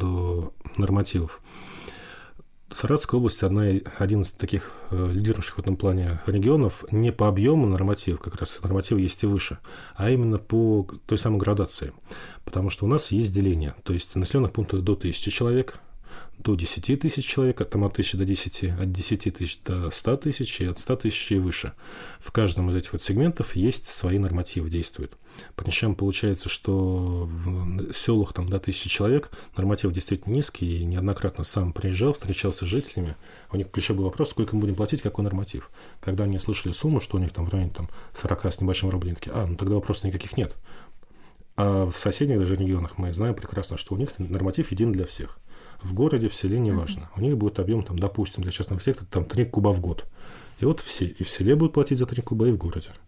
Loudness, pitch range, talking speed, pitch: -25 LUFS, 90-110 Hz, 195 wpm, 100 Hz